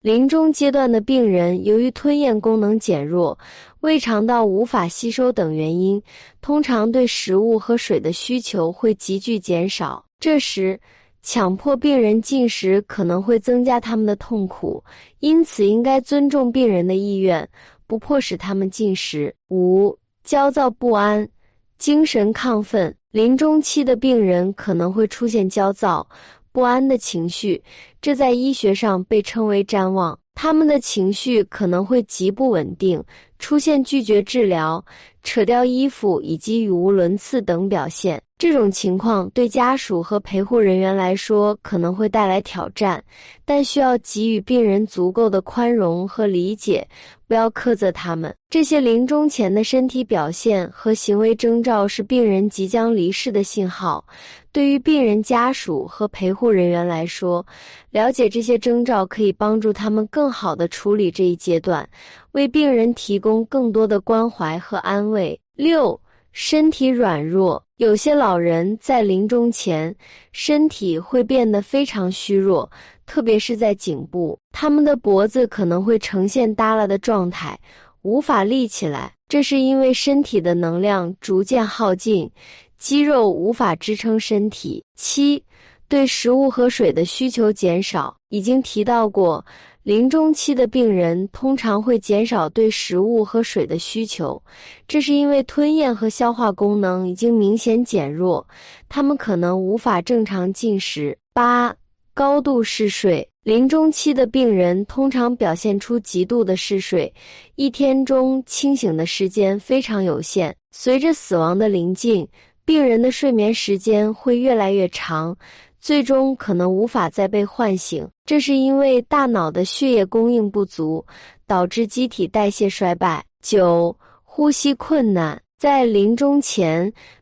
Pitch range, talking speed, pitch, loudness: 190-255 Hz, 225 characters per minute, 220 Hz, -18 LUFS